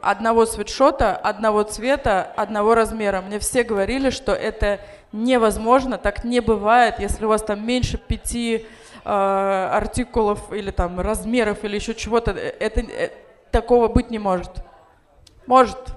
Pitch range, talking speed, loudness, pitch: 210-245 Hz, 135 wpm, -20 LUFS, 225 Hz